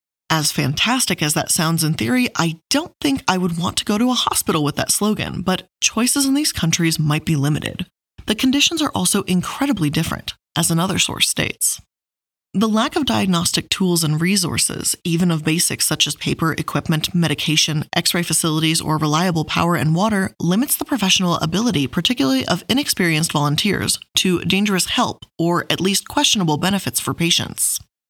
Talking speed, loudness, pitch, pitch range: 170 wpm, -18 LUFS, 170 Hz, 155-195 Hz